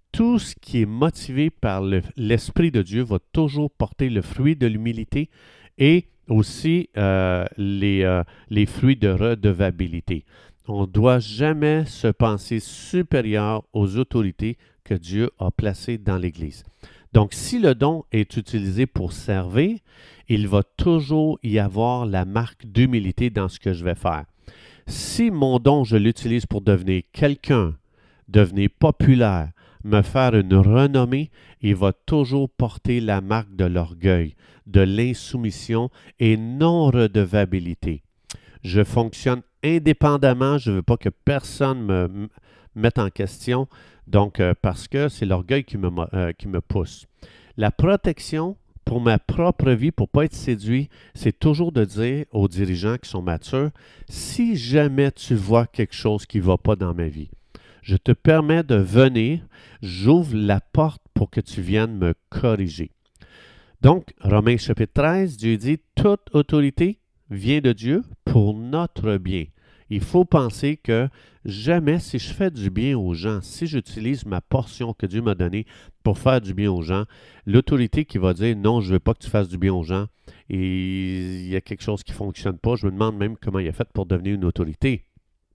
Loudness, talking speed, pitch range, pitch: -21 LUFS, 170 wpm, 100-135 Hz, 110 Hz